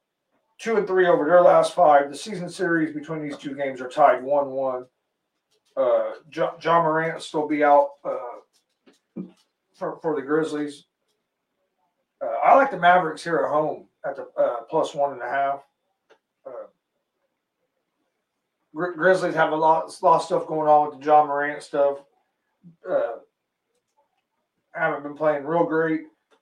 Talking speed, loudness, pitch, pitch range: 160 wpm, -22 LUFS, 155 Hz, 145-170 Hz